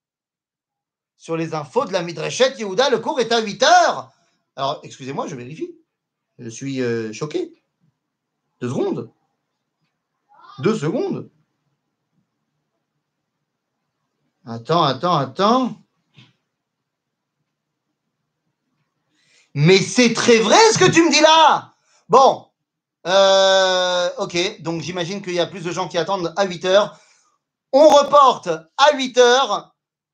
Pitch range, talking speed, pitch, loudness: 165-250 Hz, 115 wpm, 190 Hz, -17 LUFS